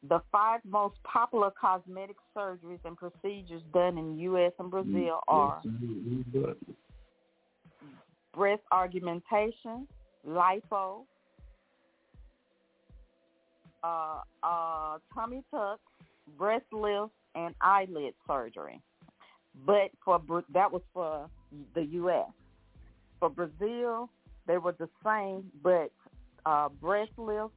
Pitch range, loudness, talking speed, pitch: 170-210 Hz, -32 LUFS, 95 wpm, 185 Hz